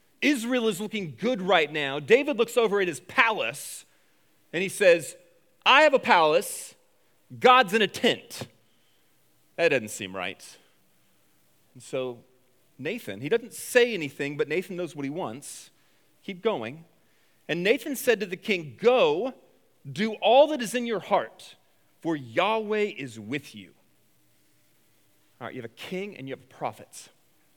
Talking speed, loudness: 155 wpm, -25 LUFS